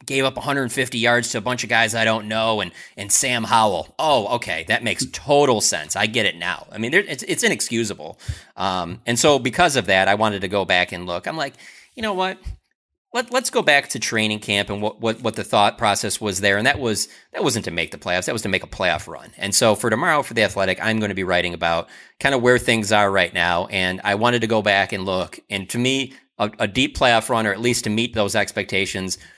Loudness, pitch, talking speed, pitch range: -20 LUFS, 110 Hz, 255 wpm, 95-125 Hz